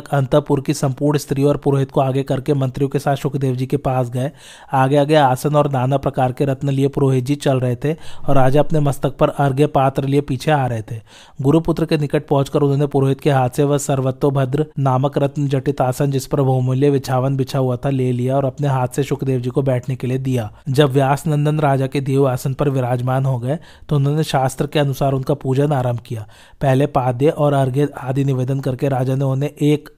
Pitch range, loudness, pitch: 130-145 Hz, -18 LUFS, 140 Hz